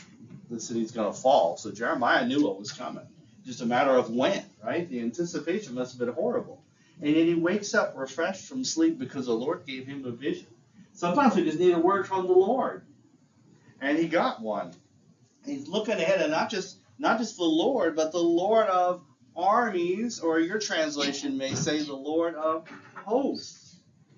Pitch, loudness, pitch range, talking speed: 170 Hz, -27 LUFS, 140-215 Hz, 190 wpm